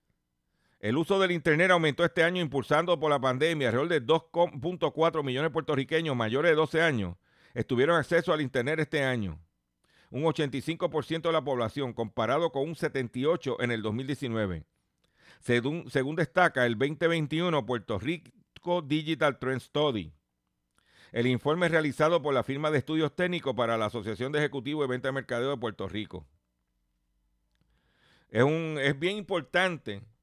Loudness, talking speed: -28 LUFS, 150 wpm